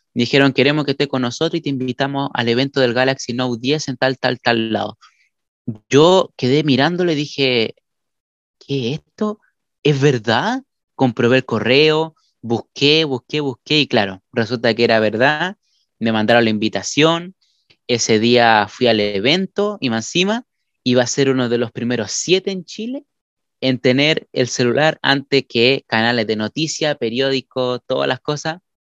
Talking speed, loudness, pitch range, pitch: 160 wpm, -17 LUFS, 120-150 Hz, 130 Hz